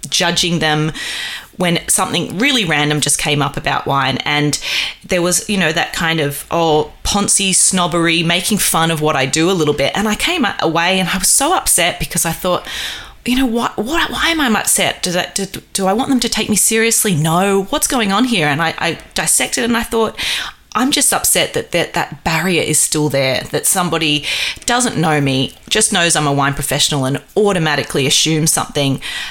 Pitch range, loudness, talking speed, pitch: 150-210 Hz, -14 LUFS, 205 wpm, 170 Hz